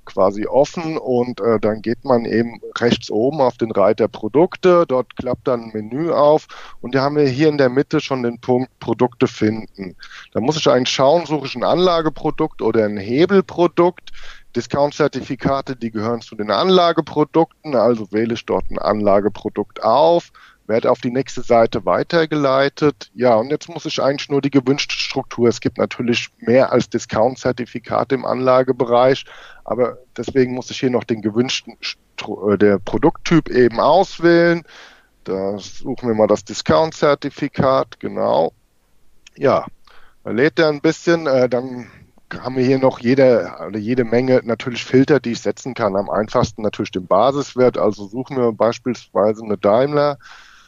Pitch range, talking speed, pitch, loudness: 115-145 Hz, 155 wpm, 130 Hz, -18 LUFS